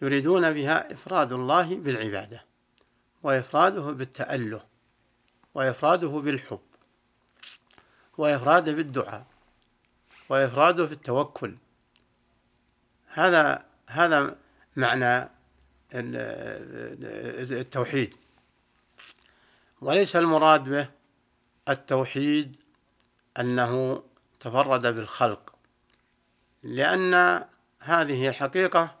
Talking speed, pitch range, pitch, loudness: 55 wpm, 120-155 Hz, 135 Hz, -25 LUFS